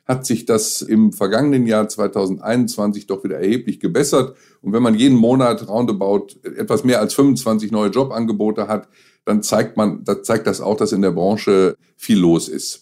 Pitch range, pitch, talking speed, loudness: 105-120 Hz, 110 Hz, 180 wpm, -17 LUFS